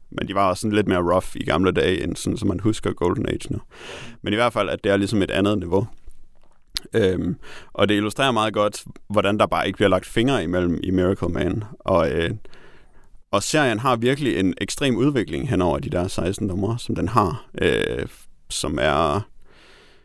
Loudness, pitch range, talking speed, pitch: -22 LUFS, 90-110 Hz, 200 wpm, 100 Hz